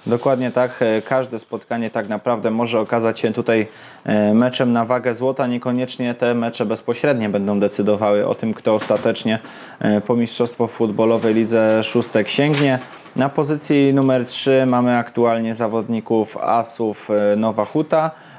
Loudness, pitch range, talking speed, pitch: -19 LUFS, 110-125 Hz, 130 wpm, 115 Hz